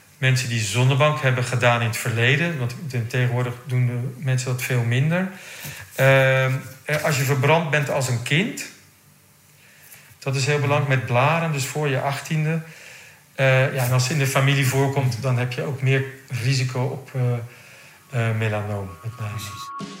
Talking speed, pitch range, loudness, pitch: 165 wpm, 125-145 Hz, -22 LUFS, 130 Hz